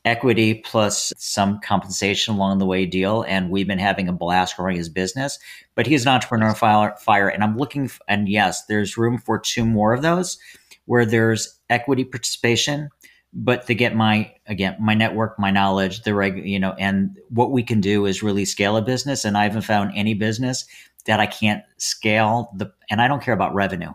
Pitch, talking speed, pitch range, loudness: 110 Hz, 200 wpm, 100-120 Hz, -20 LUFS